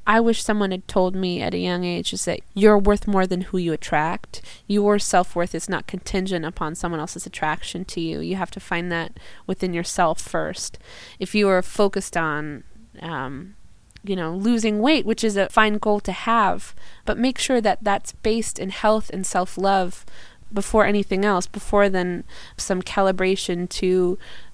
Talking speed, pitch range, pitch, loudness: 185 wpm, 175-205 Hz, 190 Hz, -22 LUFS